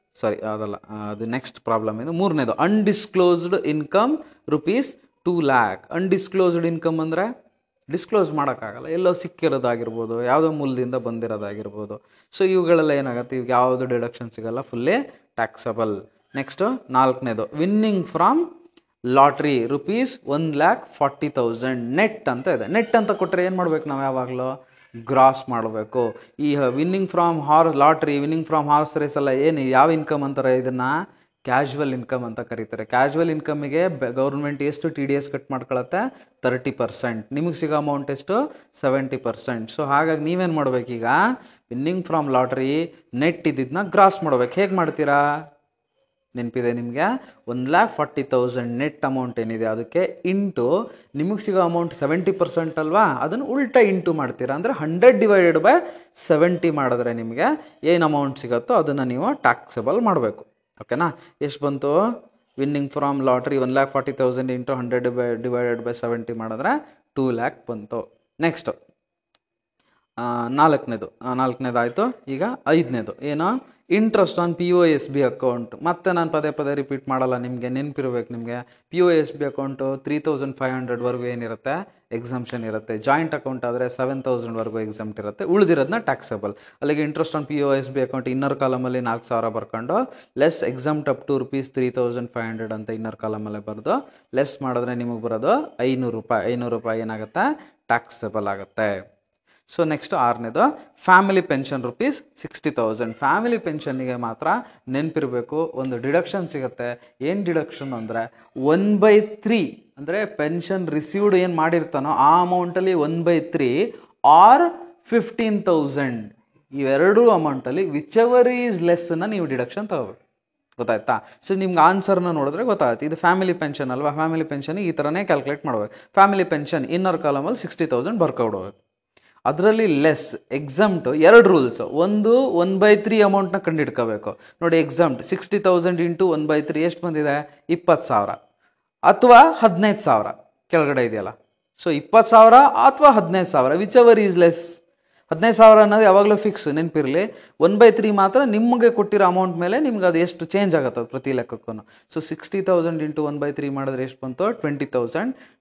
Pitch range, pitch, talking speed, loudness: 125-180 Hz, 150 Hz, 145 wpm, -20 LUFS